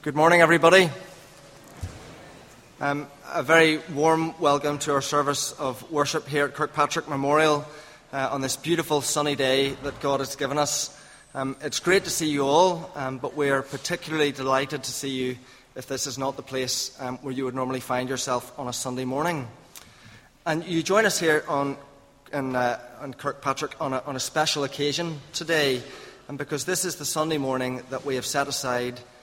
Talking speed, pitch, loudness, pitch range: 185 wpm, 140 Hz, -25 LUFS, 130-150 Hz